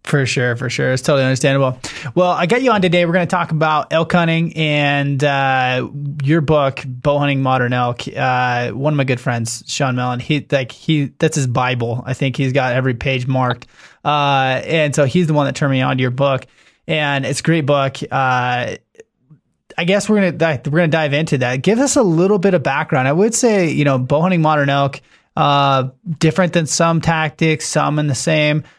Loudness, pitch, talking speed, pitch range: -16 LUFS, 145 Hz, 215 wpm, 130-160 Hz